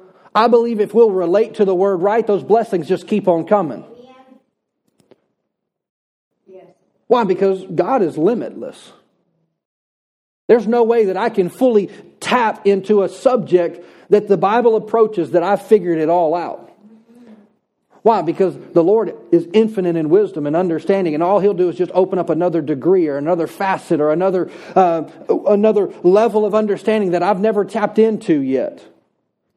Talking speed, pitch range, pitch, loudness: 155 wpm, 180-220 Hz, 200 Hz, -16 LUFS